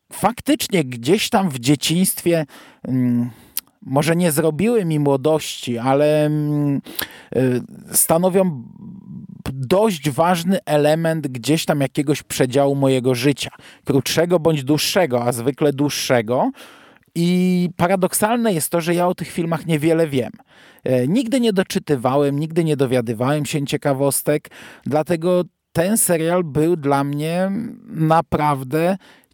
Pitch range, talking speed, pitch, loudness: 140-180 Hz, 110 wpm, 160 Hz, -19 LUFS